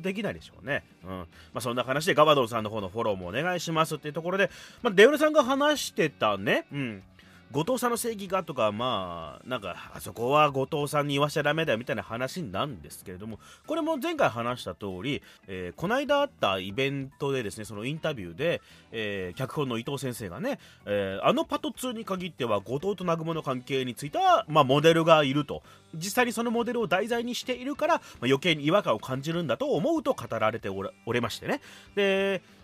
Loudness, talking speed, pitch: -27 LUFS, 430 characters per minute, 150 Hz